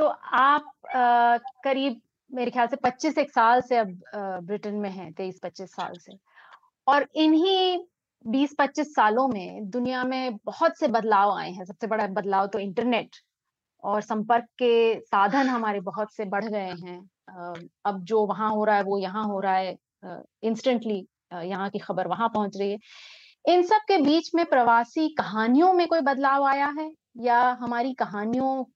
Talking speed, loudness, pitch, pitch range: 165 wpm, -25 LUFS, 235 Hz, 205-275 Hz